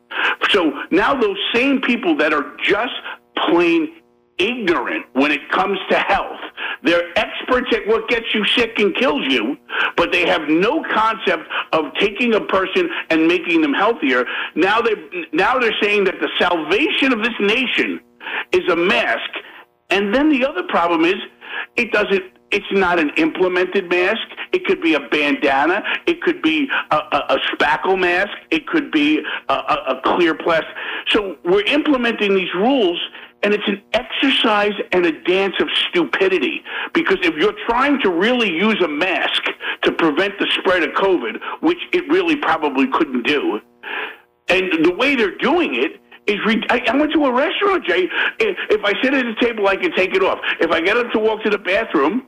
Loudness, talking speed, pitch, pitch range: -17 LUFS, 180 wpm, 270 Hz, 205-345 Hz